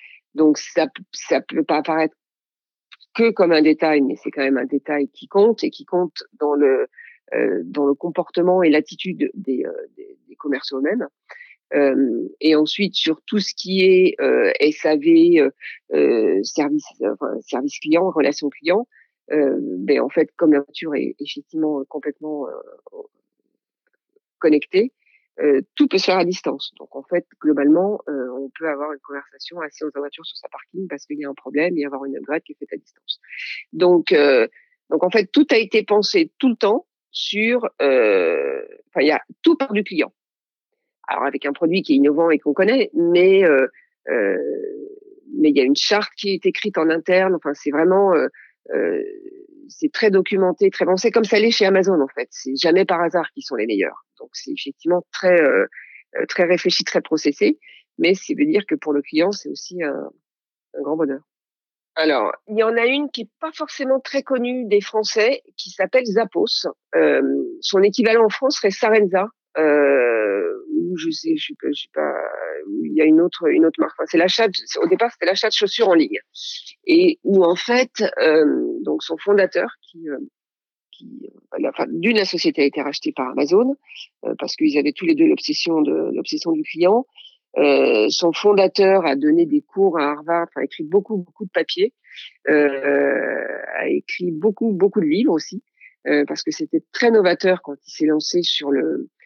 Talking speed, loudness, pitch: 190 wpm, -19 LUFS, 210 Hz